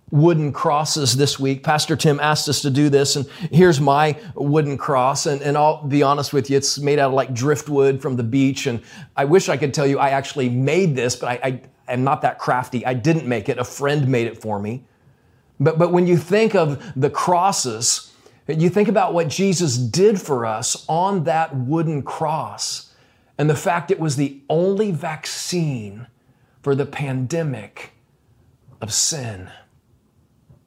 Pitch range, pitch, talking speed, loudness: 130-160 Hz, 140 Hz, 180 wpm, -19 LUFS